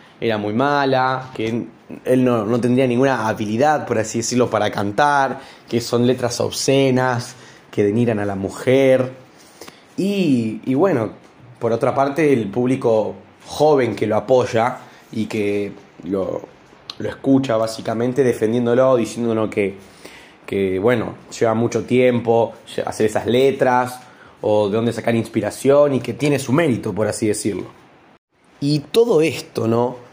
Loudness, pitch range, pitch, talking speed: -19 LUFS, 110-130 Hz, 120 Hz, 140 wpm